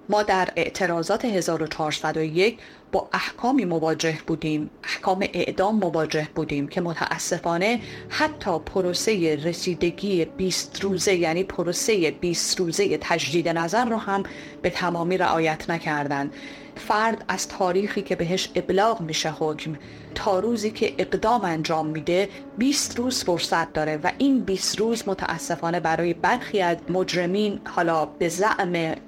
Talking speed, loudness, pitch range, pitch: 125 wpm, -24 LUFS, 160-195 Hz, 175 Hz